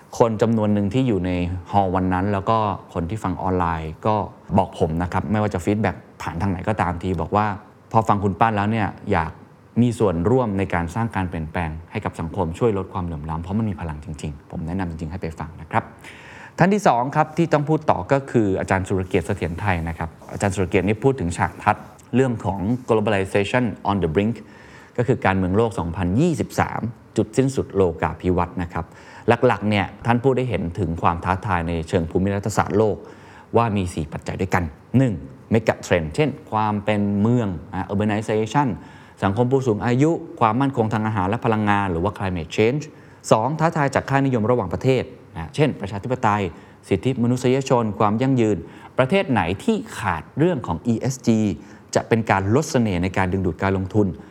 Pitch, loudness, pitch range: 105 Hz, -22 LUFS, 90-120 Hz